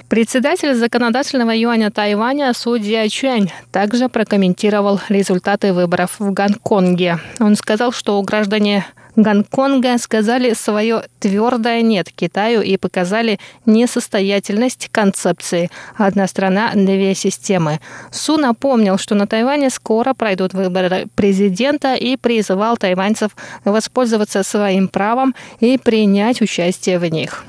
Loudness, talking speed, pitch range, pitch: -15 LUFS, 110 wpm, 195-235 Hz, 215 Hz